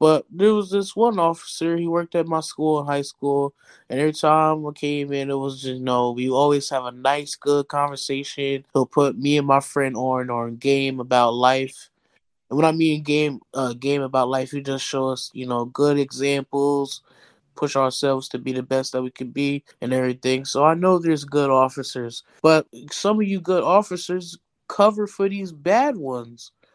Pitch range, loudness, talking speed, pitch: 130-155 Hz, -22 LUFS, 200 wpm, 140 Hz